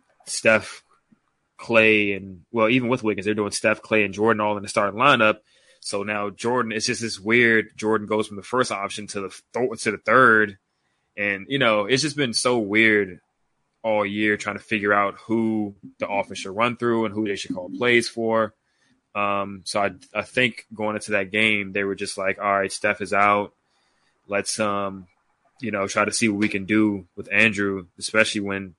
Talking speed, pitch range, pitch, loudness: 200 wpm, 100-110 Hz, 105 Hz, -22 LUFS